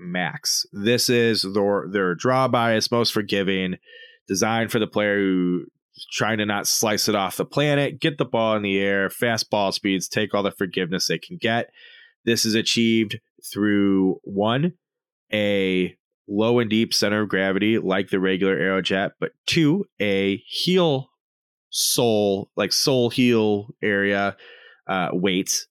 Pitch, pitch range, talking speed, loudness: 105 Hz, 100-120 Hz, 150 wpm, -22 LUFS